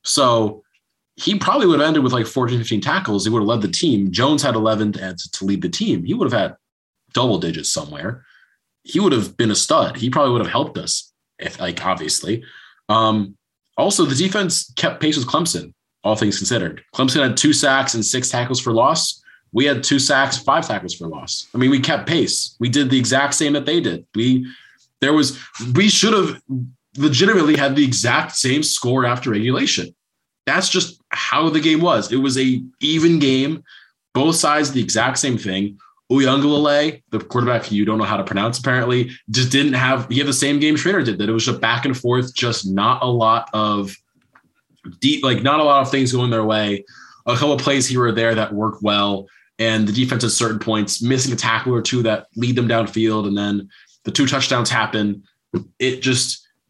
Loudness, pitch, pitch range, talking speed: -18 LUFS, 125 Hz, 110-140 Hz, 205 wpm